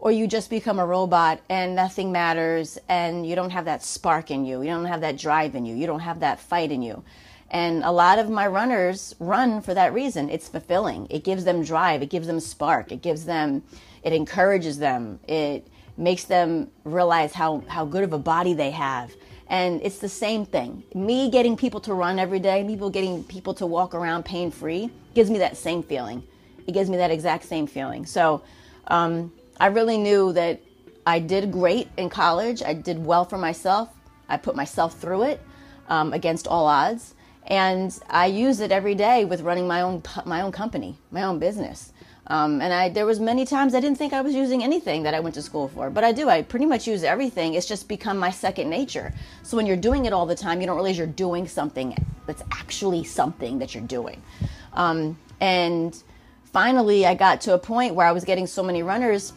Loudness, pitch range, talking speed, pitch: -23 LUFS, 165-200 Hz, 220 wpm, 180 Hz